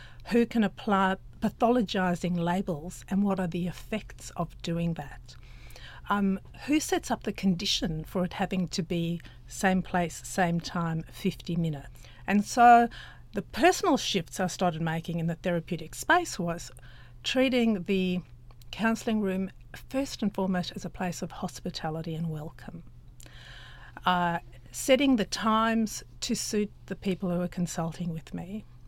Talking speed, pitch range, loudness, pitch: 145 wpm, 160-200 Hz, -29 LUFS, 180 Hz